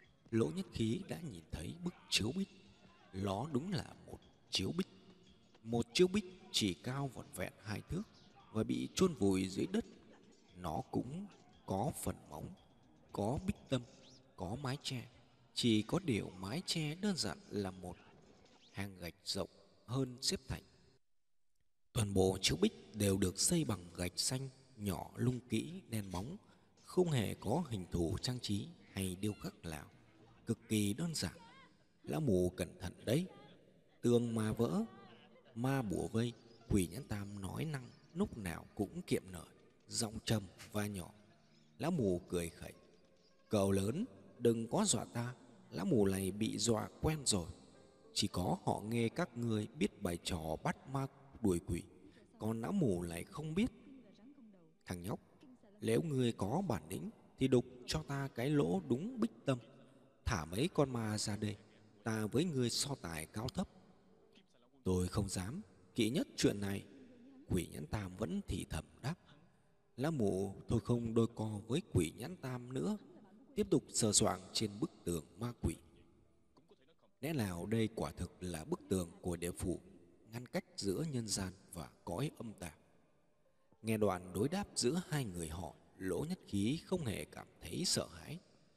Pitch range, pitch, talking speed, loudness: 95-140 Hz, 115 Hz, 165 wpm, -39 LUFS